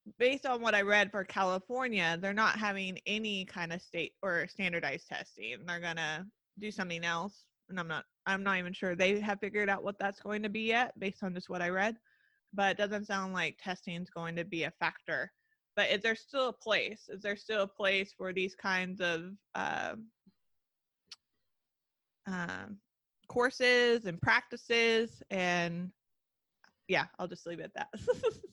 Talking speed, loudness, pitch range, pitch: 180 wpm, -33 LUFS, 180-220 Hz, 195 Hz